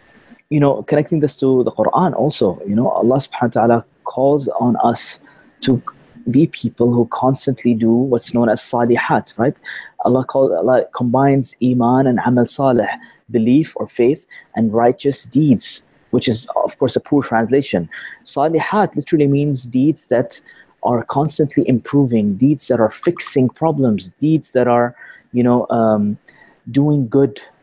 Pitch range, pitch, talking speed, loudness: 120-140 Hz, 130 Hz, 150 wpm, -16 LUFS